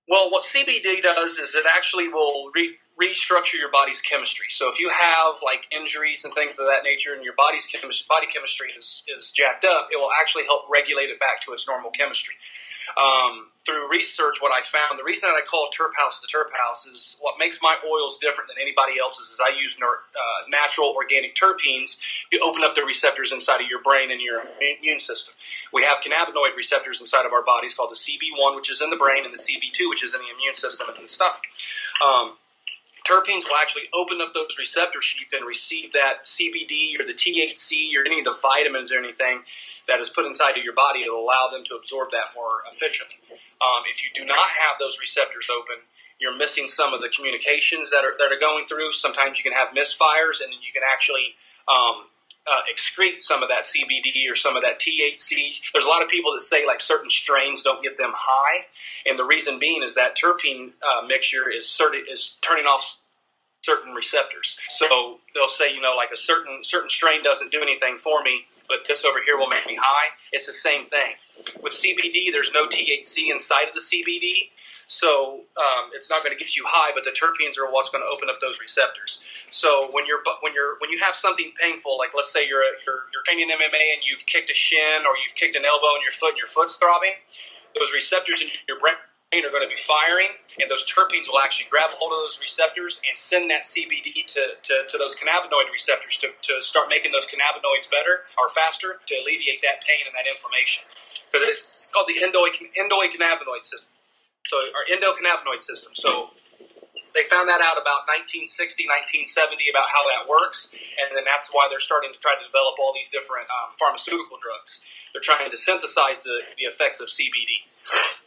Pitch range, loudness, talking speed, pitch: 140-225 Hz, -20 LUFS, 210 wpm, 160 Hz